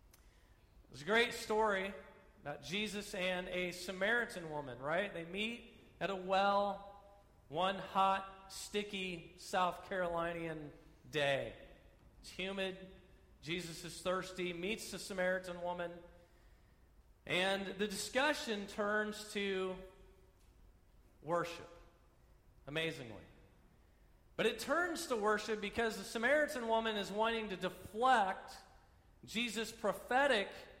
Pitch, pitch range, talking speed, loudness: 190 Hz, 170-210 Hz, 105 wpm, -38 LUFS